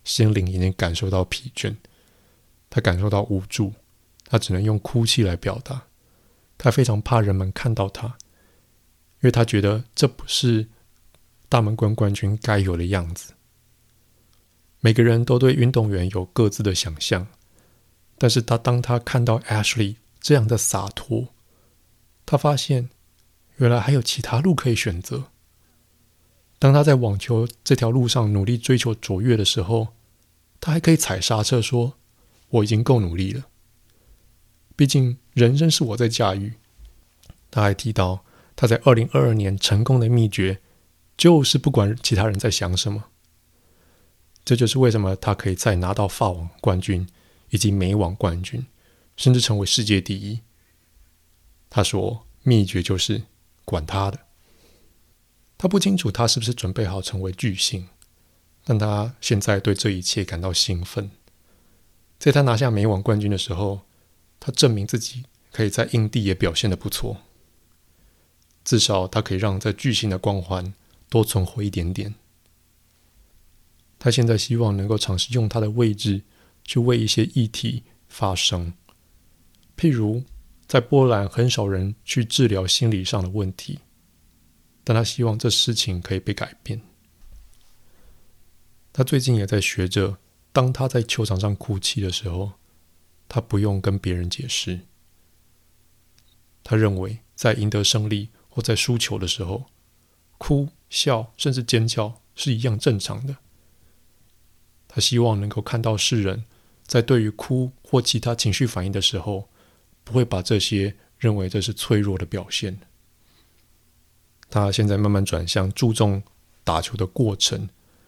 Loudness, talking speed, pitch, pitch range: -21 LUFS, 220 characters per minute, 105 Hz, 90-120 Hz